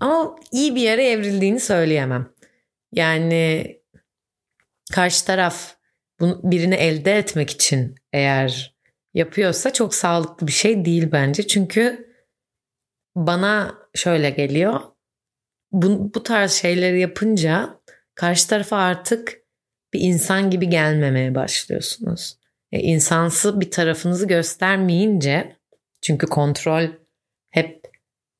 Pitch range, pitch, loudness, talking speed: 160-200 Hz, 175 Hz, -19 LUFS, 100 wpm